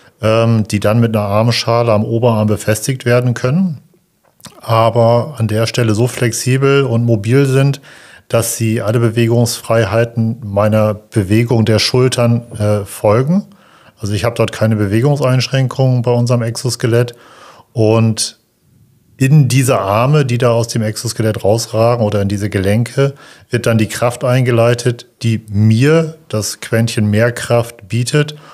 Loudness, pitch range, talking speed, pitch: -14 LUFS, 110-130 Hz, 130 wpm, 115 Hz